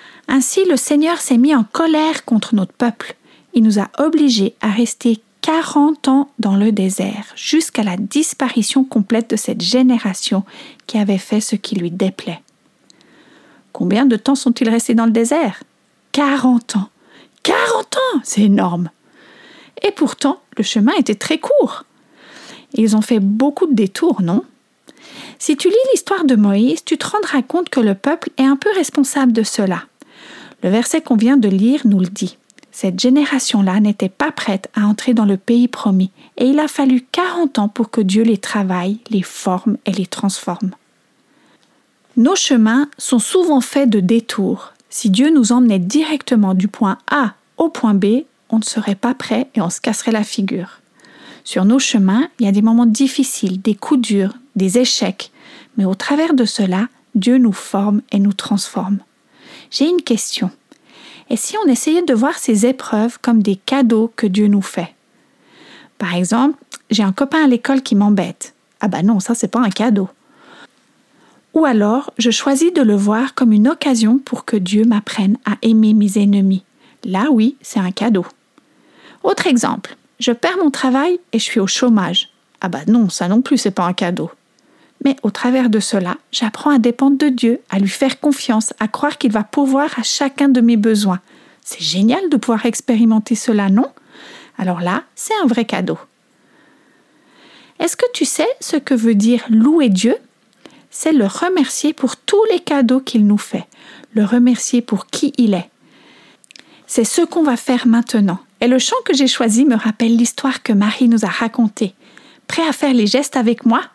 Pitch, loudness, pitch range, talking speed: 240 Hz, -15 LUFS, 215-280 Hz, 180 wpm